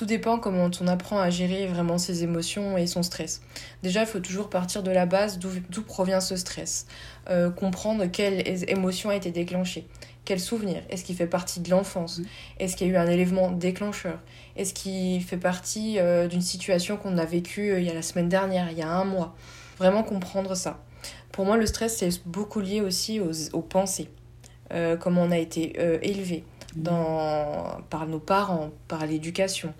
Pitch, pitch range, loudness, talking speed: 180 Hz, 170-195 Hz, -27 LUFS, 195 wpm